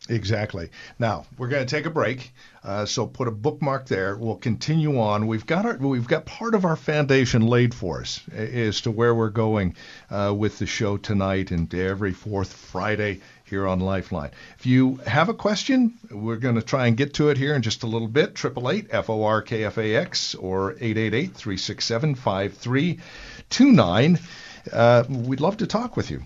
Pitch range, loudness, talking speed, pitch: 105-145 Hz, -23 LUFS, 175 wpm, 115 Hz